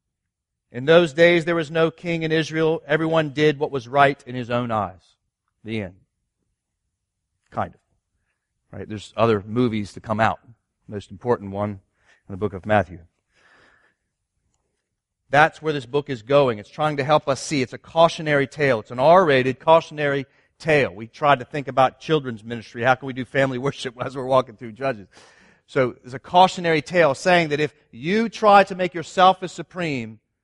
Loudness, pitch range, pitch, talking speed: -21 LUFS, 110-155 Hz, 135 Hz, 180 wpm